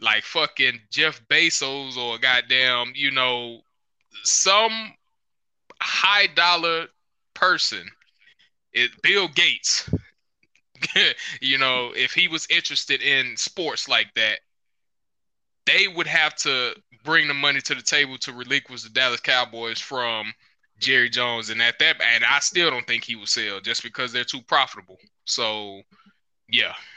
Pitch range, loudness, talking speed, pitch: 120-150 Hz, -20 LUFS, 135 wpm, 125 Hz